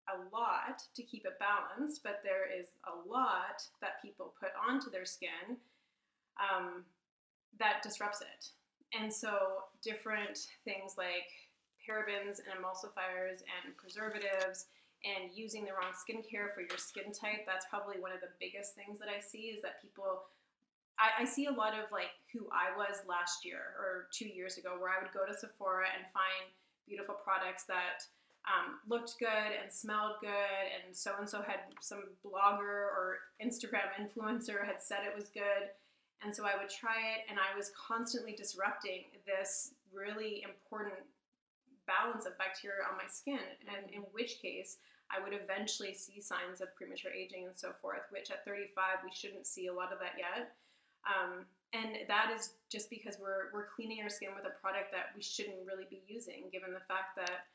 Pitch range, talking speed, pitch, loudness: 190-215 Hz, 180 wpm, 200 Hz, -40 LUFS